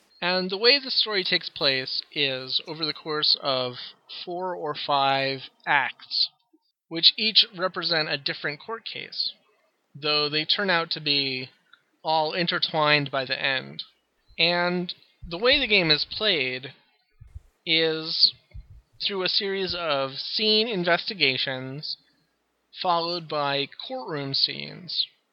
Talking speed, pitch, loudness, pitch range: 125 wpm, 160 Hz, -24 LUFS, 140-185 Hz